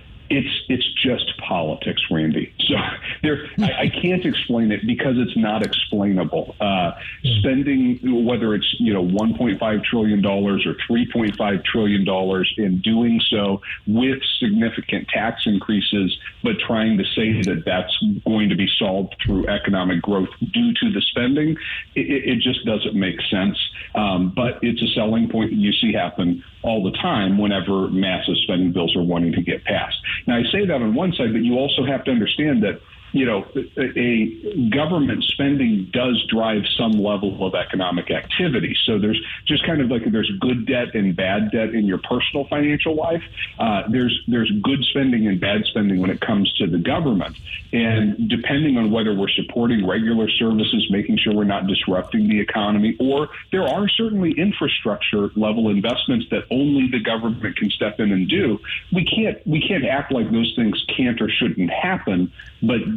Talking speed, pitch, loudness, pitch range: 175 wpm, 110 Hz, -20 LUFS, 100-130 Hz